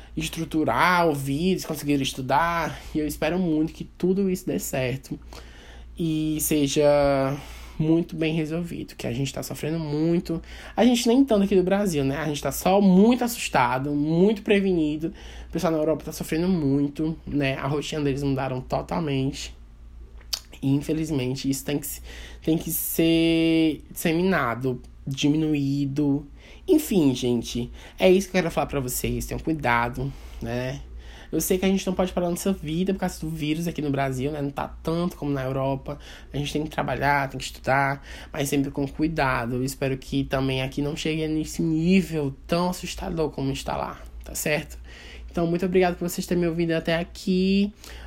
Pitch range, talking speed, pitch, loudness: 135-170 Hz, 170 wpm, 150 Hz, -25 LUFS